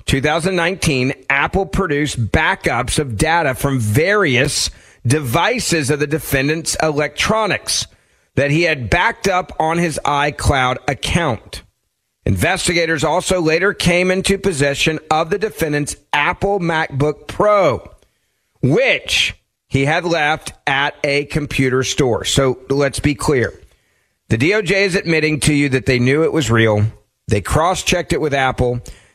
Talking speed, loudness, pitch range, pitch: 130 wpm, -16 LUFS, 130-170 Hz, 150 Hz